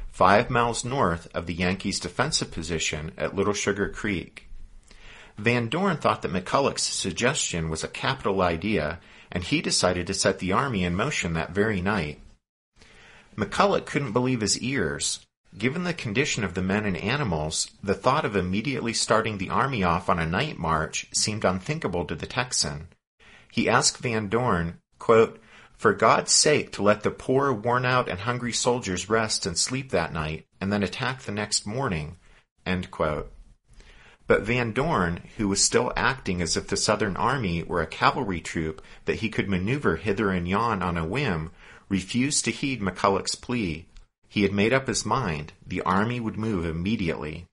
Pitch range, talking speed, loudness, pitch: 90-120 Hz, 170 wpm, -25 LUFS, 100 Hz